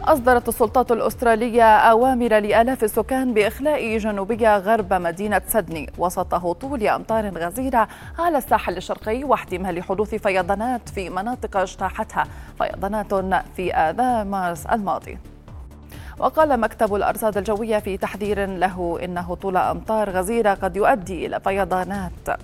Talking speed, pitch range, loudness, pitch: 120 wpm, 185-230 Hz, -21 LUFS, 210 Hz